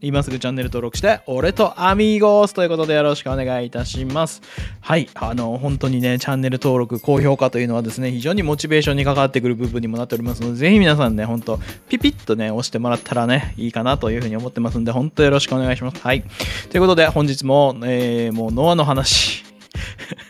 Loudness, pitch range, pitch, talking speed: -18 LUFS, 115-145 Hz, 125 Hz, 490 characters per minute